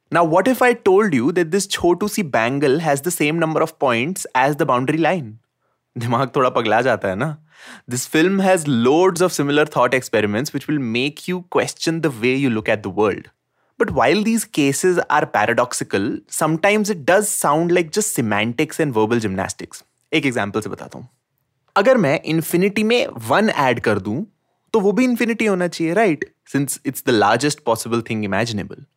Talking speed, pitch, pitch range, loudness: 150 wpm, 155 Hz, 130-185 Hz, -18 LUFS